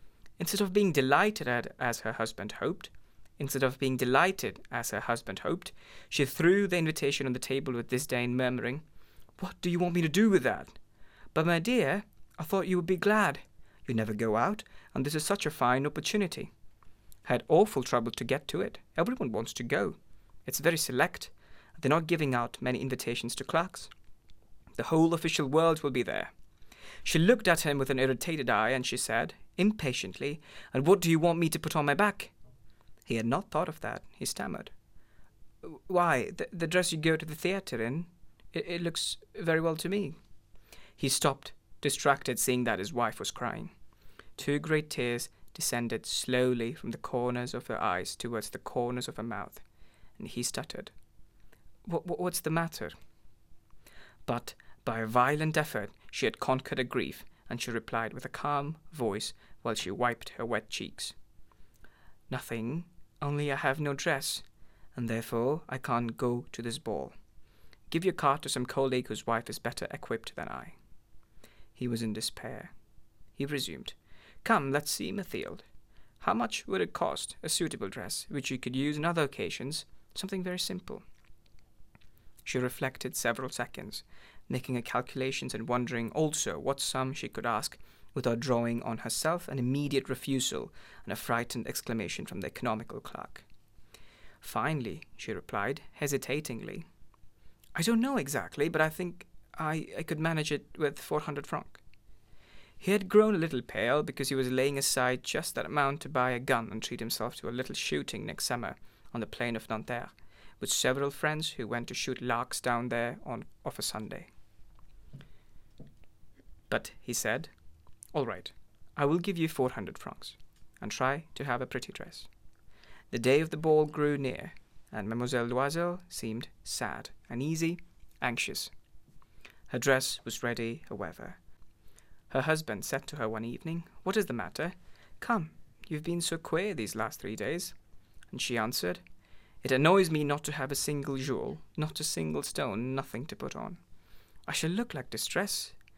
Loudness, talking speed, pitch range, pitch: -32 LUFS, 175 wpm, 115-155 Hz, 130 Hz